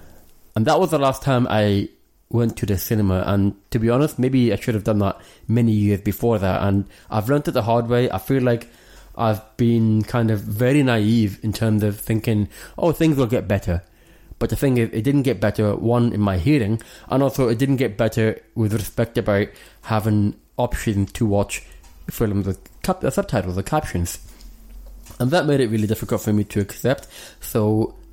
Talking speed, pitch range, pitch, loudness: 195 wpm, 100-120 Hz, 110 Hz, -21 LUFS